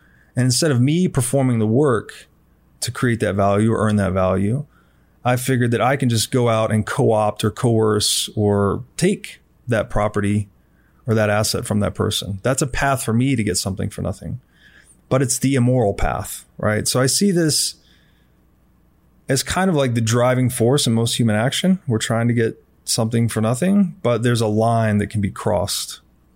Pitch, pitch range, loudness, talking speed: 115 Hz, 105-130 Hz, -19 LUFS, 190 wpm